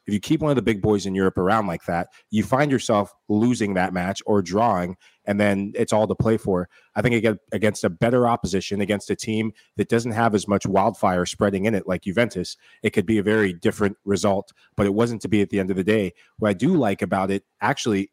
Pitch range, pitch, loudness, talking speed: 100-110 Hz, 105 Hz, -22 LUFS, 240 wpm